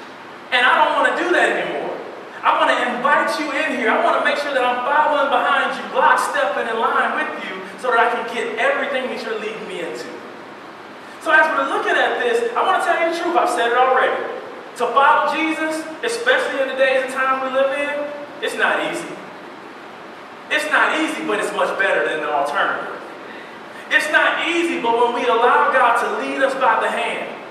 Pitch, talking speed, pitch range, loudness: 290 Hz, 215 wpm, 250-315 Hz, -18 LUFS